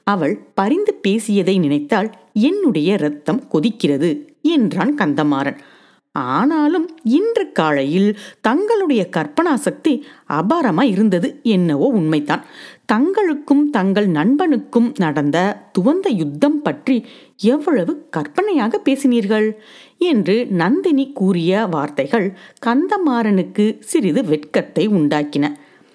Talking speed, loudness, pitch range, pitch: 85 wpm, -17 LUFS, 185-290 Hz, 230 Hz